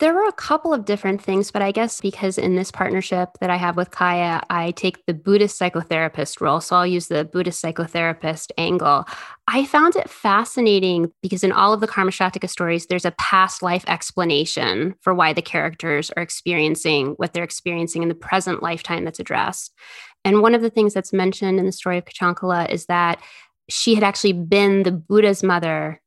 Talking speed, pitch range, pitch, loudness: 195 wpm, 170-195 Hz, 180 Hz, -20 LUFS